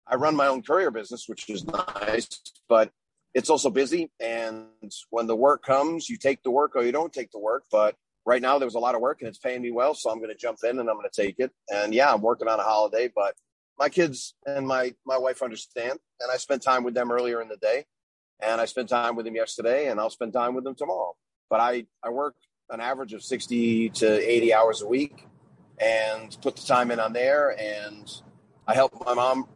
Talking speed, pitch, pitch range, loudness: 235 wpm, 125 Hz, 115-135 Hz, -25 LUFS